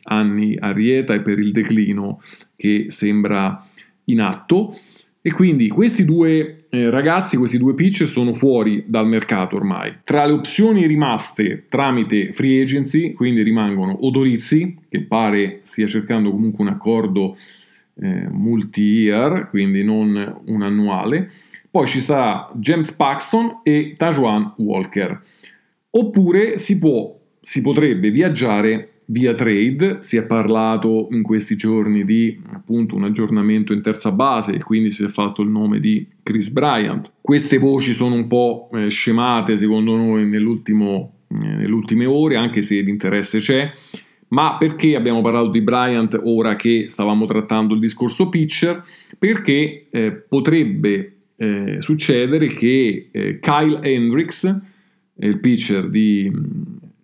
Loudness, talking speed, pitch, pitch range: -17 LUFS, 135 wpm, 120 Hz, 105-155 Hz